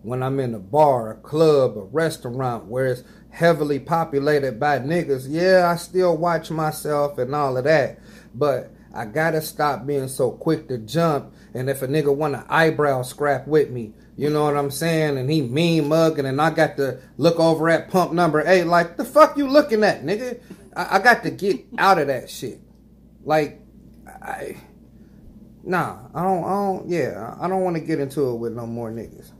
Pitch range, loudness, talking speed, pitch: 140-170 Hz, -21 LUFS, 195 wpm, 155 Hz